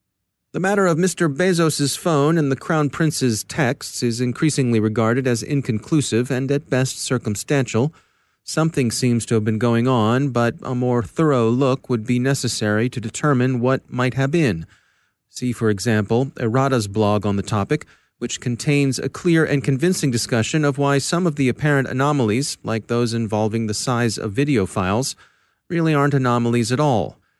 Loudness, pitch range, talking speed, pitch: -20 LUFS, 115-145 Hz, 165 wpm, 130 Hz